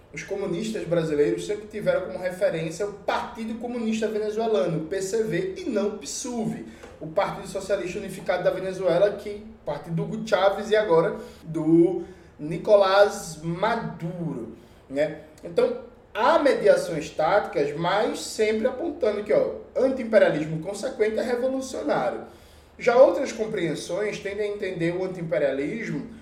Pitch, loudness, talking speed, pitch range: 200 Hz, -25 LUFS, 125 wpm, 175-225 Hz